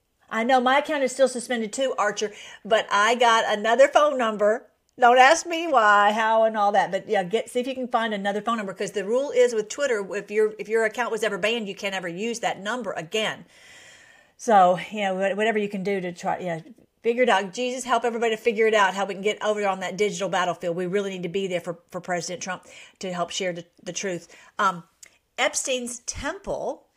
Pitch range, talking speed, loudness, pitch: 195-240 Hz, 225 wpm, -23 LUFS, 215 Hz